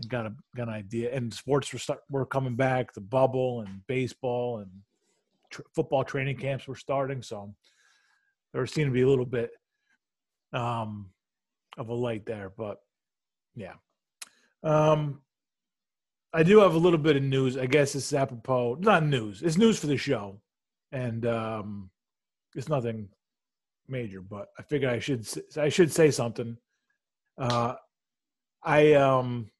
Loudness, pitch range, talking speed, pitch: -27 LUFS, 115-150 Hz, 155 wpm, 130 Hz